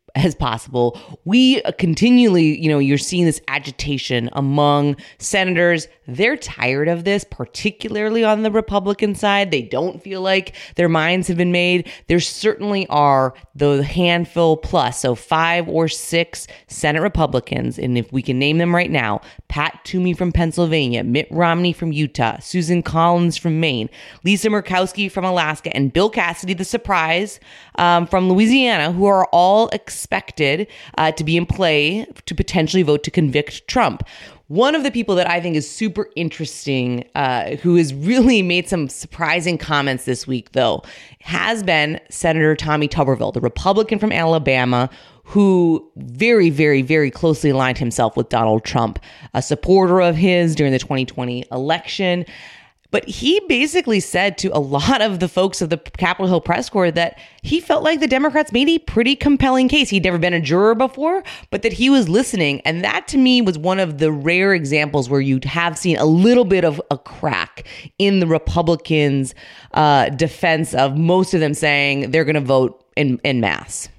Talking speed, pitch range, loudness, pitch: 175 wpm, 145-190 Hz, -17 LUFS, 170 Hz